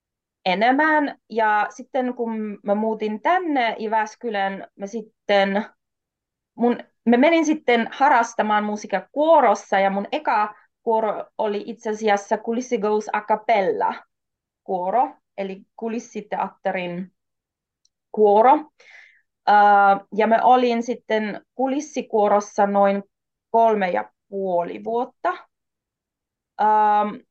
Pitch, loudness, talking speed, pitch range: 220 Hz, -21 LUFS, 90 wpm, 205-245 Hz